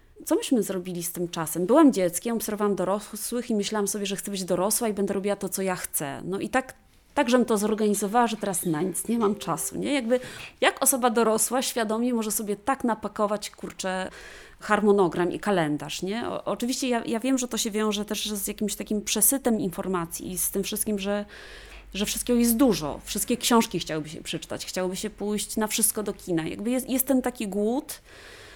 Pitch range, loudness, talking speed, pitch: 190-235 Hz, -26 LUFS, 200 wpm, 210 Hz